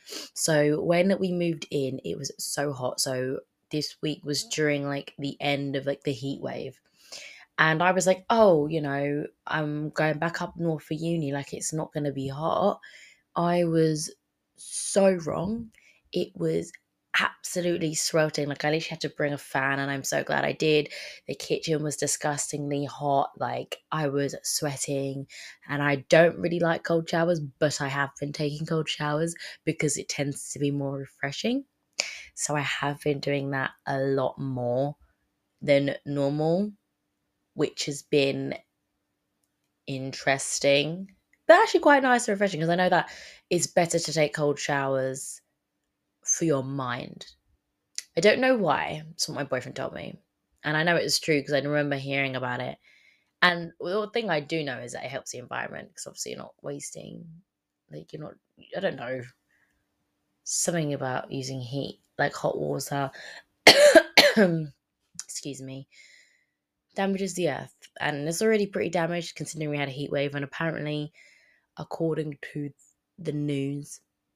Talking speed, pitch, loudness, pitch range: 165 wpm, 150 Hz, -26 LUFS, 140-165 Hz